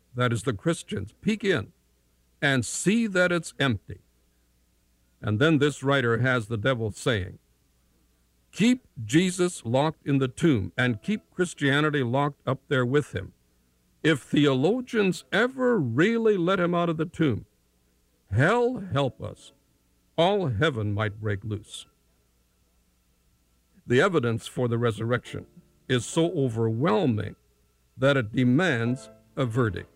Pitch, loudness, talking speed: 125 Hz, -25 LUFS, 130 wpm